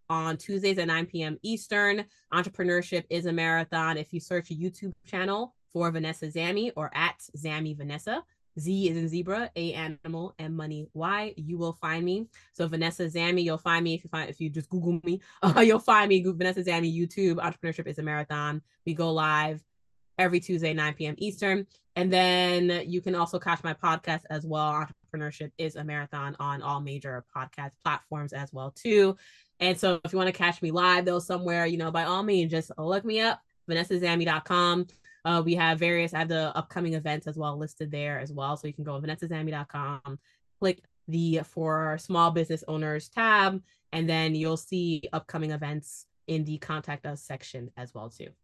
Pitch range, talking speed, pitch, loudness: 155-180 Hz, 190 wpm, 165 Hz, -28 LUFS